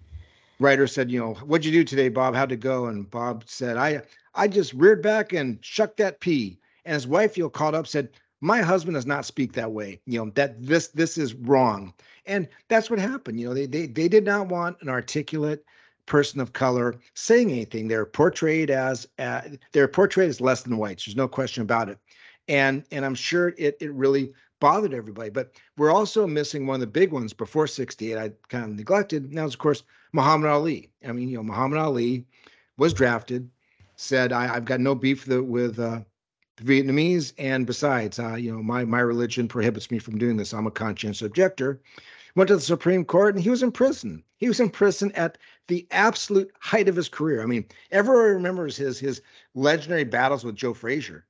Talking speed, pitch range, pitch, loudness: 210 wpm, 120-170 Hz, 135 Hz, -24 LUFS